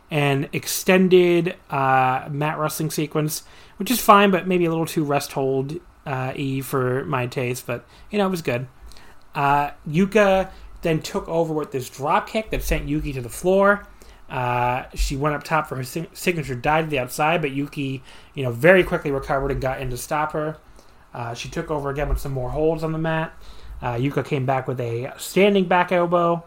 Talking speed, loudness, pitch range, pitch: 195 wpm, -22 LUFS, 135-170 Hz, 150 Hz